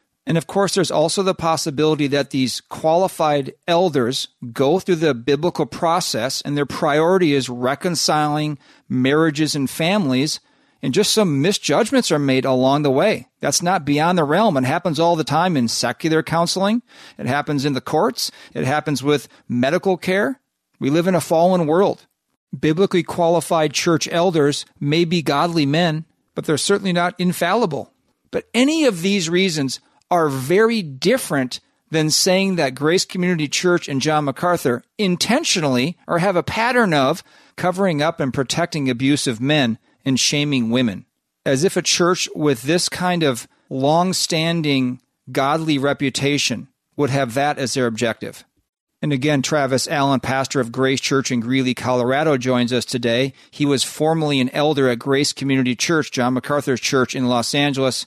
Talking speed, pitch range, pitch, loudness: 160 wpm, 135-175 Hz, 150 Hz, -19 LUFS